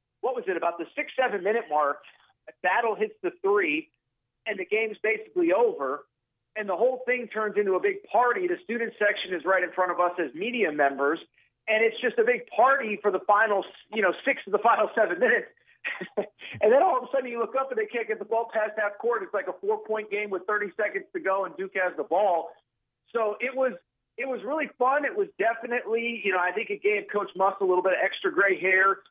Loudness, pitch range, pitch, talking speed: -26 LUFS, 195-300 Hz, 225 Hz, 240 wpm